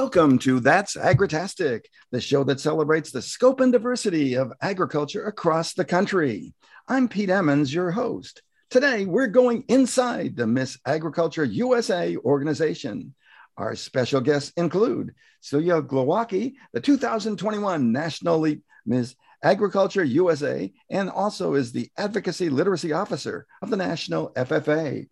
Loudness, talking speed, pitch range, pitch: -23 LUFS, 130 wpm, 145-220 Hz, 175 Hz